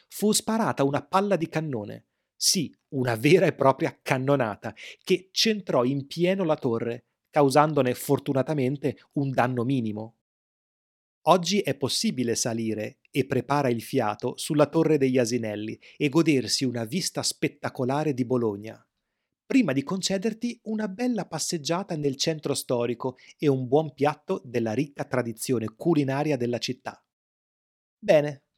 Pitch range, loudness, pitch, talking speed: 125-160 Hz, -26 LUFS, 140 Hz, 130 wpm